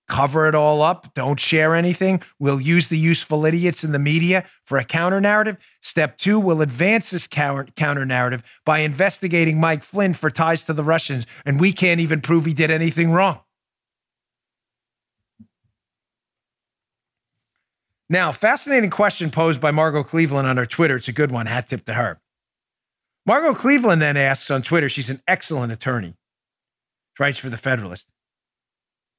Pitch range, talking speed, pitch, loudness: 135-170 Hz, 155 wpm, 155 Hz, -19 LUFS